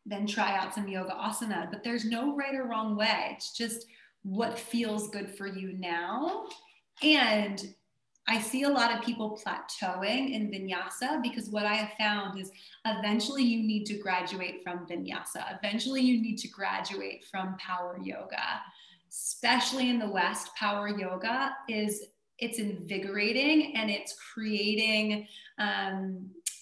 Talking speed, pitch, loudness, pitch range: 145 wpm, 215 Hz, -31 LUFS, 195-235 Hz